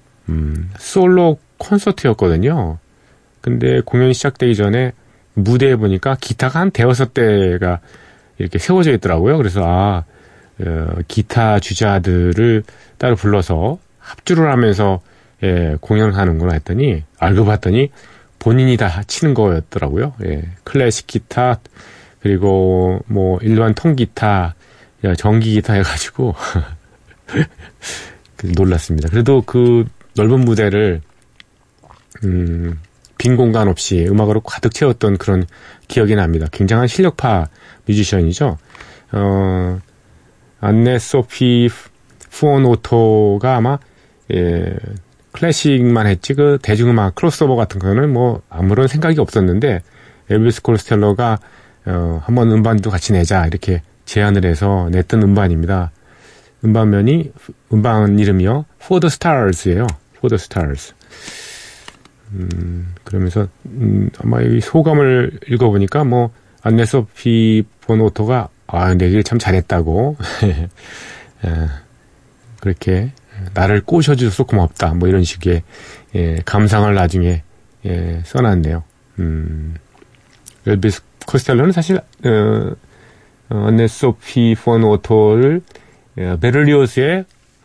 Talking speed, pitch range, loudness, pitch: 250 characters per minute, 90-125 Hz, -15 LUFS, 105 Hz